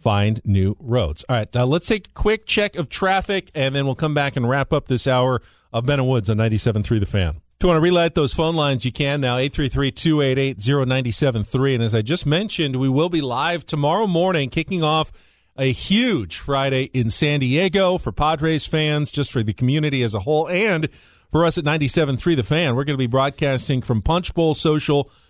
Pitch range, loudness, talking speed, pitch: 125-160 Hz, -20 LUFS, 205 wpm, 140 Hz